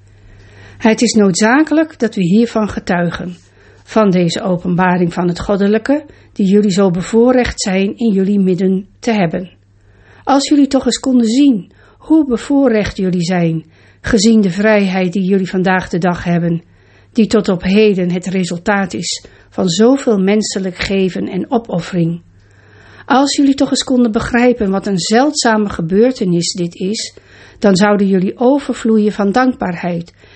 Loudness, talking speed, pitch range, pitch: -13 LUFS, 145 wpm, 180-230 Hz, 200 Hz